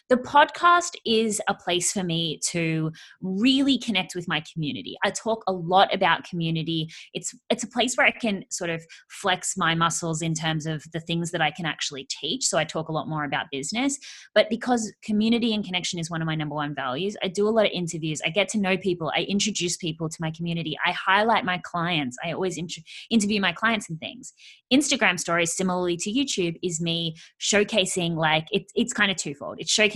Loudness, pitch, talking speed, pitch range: -24 LUFS, 180 Hz, 210 wpm, 165-215 Hz